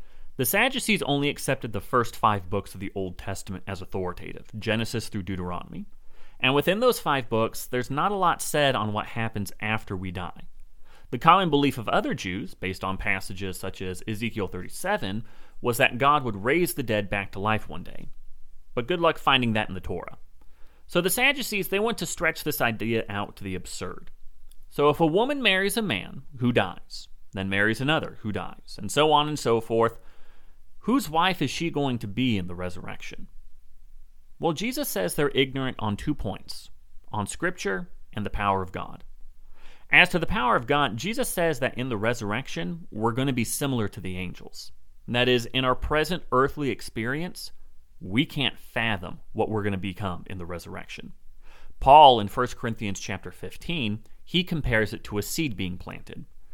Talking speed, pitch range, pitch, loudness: 190 wpm, 95-145 Hz, 110 Hz, -25 LUFS